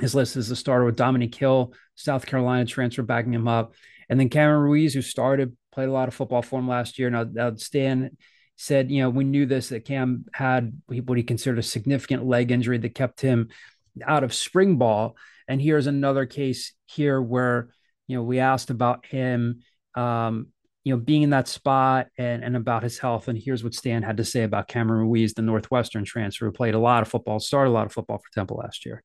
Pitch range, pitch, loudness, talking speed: 120-130 Hz, 125 Hz, -24 LUFS, 220 wpm